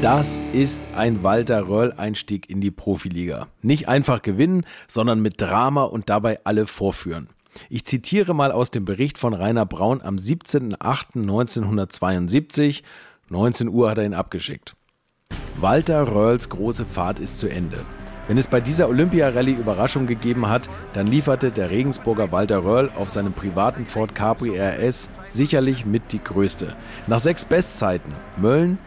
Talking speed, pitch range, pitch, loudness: 145 wpm, 100-130 Hz, 115 Hz, -21 LUFS